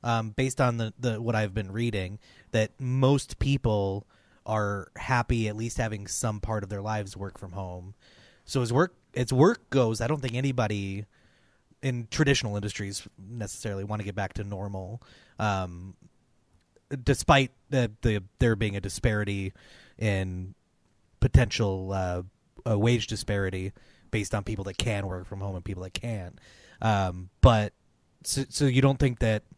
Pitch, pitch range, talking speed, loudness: 110 Hz, 100-120 Hz, 160 wpm, -28 LUFS